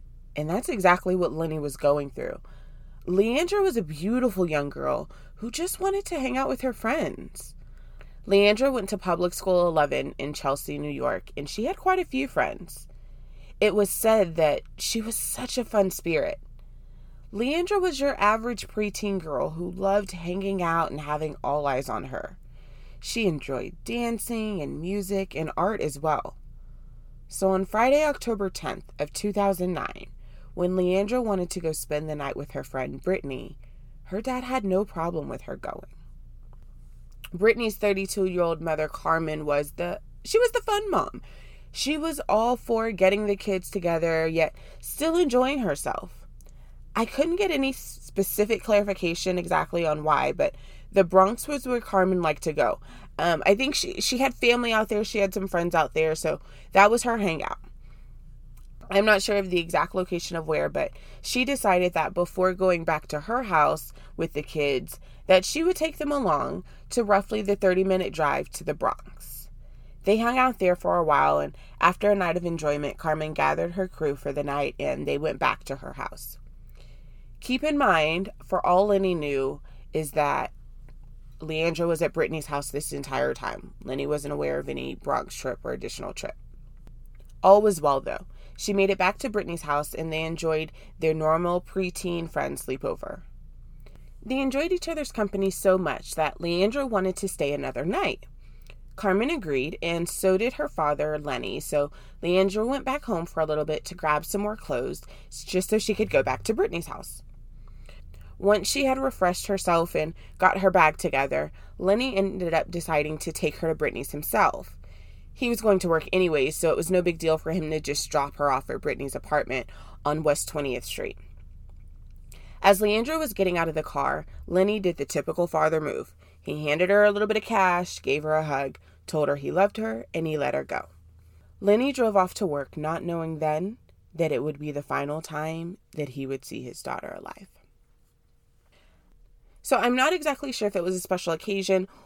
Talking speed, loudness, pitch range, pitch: 185 wpm, -26 LUFS, 150-210 Hz, 180 Hz